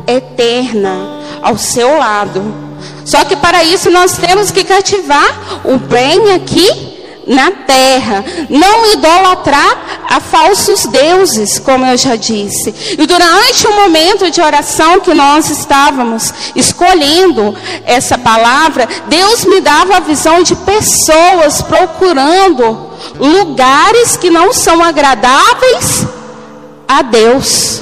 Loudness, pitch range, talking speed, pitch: -7 LUFS, 255-370 Hz, 115 wpm, 320 Hz